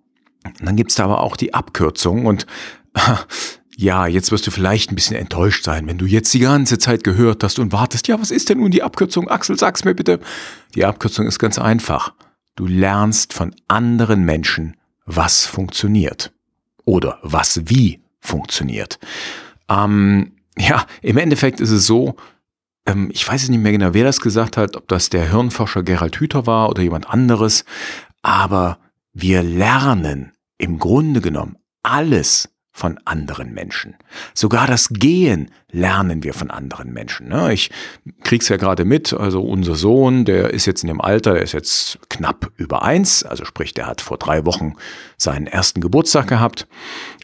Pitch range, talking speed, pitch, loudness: 90-120 Hz, 170 wpm, 105 Hz, -16 LUFS